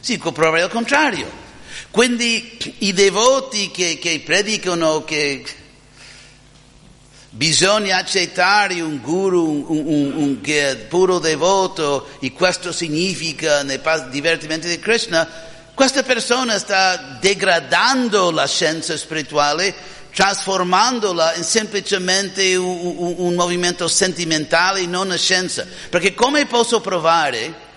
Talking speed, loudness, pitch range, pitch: 110 wpm, -17 LUFS, 155-195 Hz, 175 Hz